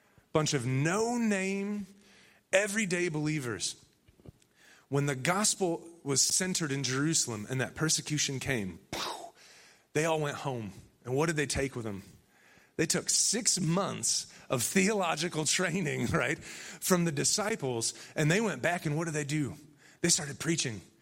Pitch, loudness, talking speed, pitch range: 155 Hz, -30 LUFS, 145 wpm, 135-185 Hz